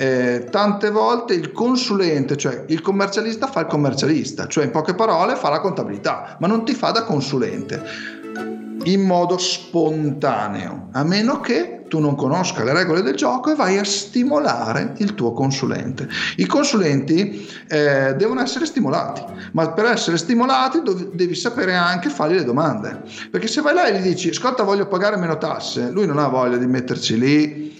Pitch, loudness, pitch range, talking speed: 180 Hz, -19 LUFS, 145-220 Hz, 170 wpm